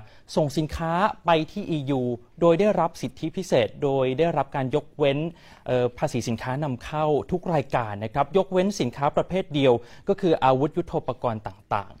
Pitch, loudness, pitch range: 150 Hz, -25 LUFS, 130-170 Hz